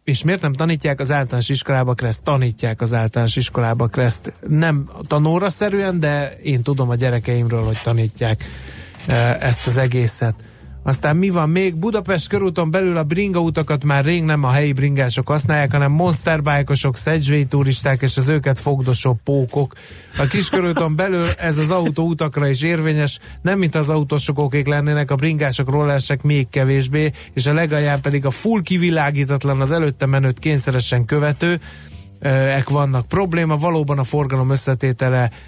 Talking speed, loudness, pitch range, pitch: 150 wpm, -18 LUFS, 130-155 Hz, 145 Hz